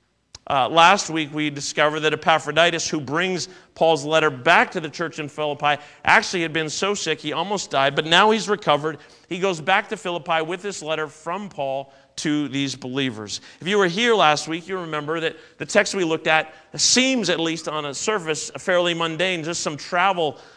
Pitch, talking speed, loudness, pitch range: 160 Hz, 200 wpm, -21 LUFS, 150-180 Hz